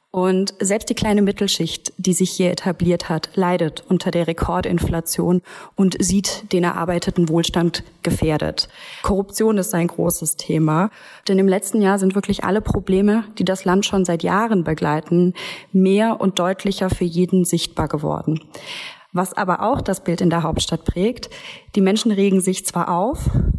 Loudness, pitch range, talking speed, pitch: -19 LUFS, 175-200 Hz, 160 wpm, 185 Hz